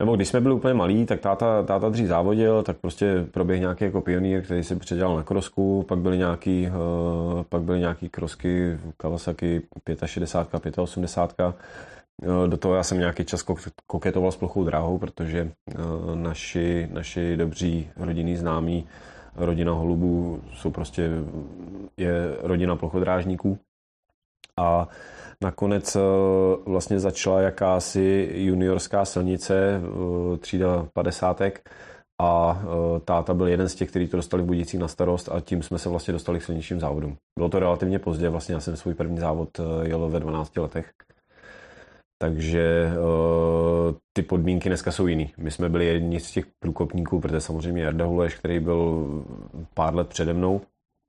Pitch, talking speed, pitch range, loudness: 85 Hz, 140 wpm, 85-95 Hz, -25 LUFS